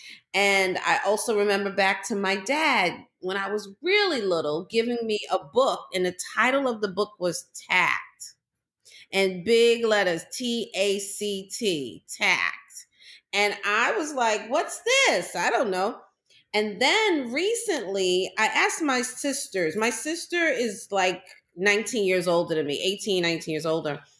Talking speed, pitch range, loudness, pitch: 155 wpm, 190-255 Hz, -24 LUFS, 205 Hz